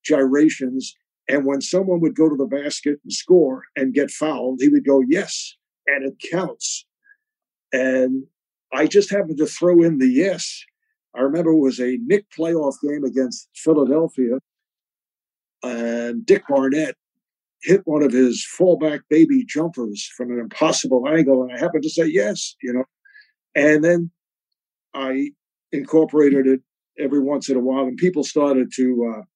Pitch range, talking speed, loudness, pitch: 130-170 Hz, 155 wpm, -19 LUFS, 145 Hz